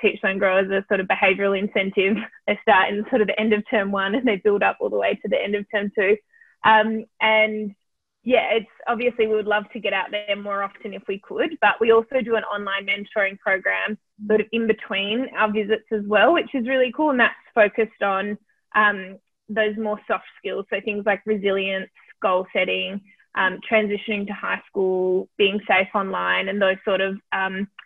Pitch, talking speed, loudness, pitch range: 210 Hz, 205 wpm, -21 LUFS, 195-220 Hz